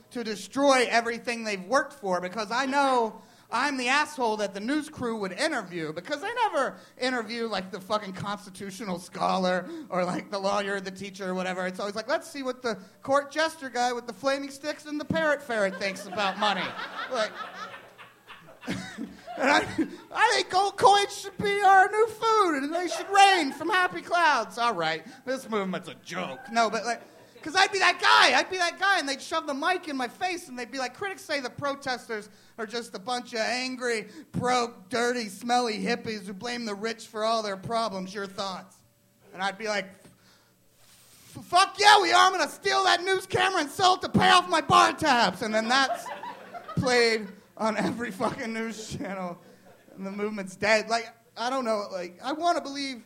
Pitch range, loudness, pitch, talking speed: 210-310 Hz, -26 LUFS, 240 Hz, 195 wpm